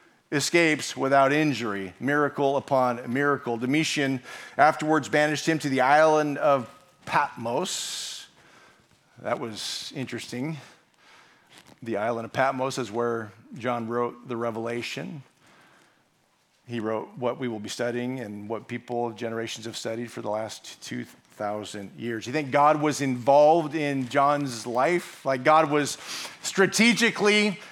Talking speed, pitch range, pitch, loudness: 125 wpm, 120-150 Hz, 130 Hz, -25 LUFS